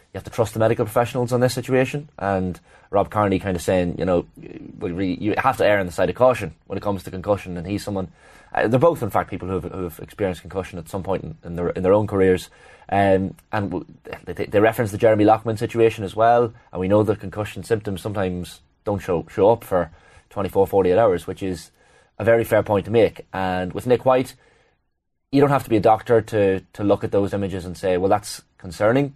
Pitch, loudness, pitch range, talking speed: 100 Hz, -21 LUFS, 95-115 Hz, 230 wpm